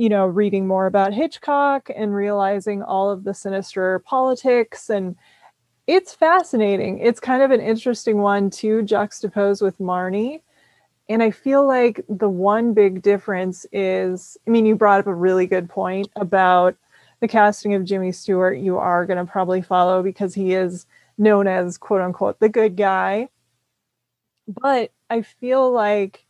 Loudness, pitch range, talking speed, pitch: -19 LUFS, 190-225 Hz, 155 wpm, 200 Hz